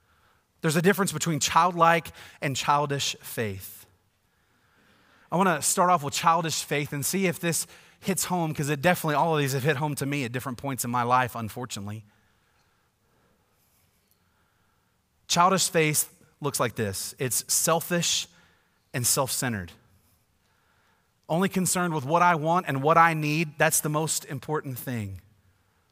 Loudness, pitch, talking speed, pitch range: -25 LUFS, 140 Hz, 150 wpm, 115-165 Hz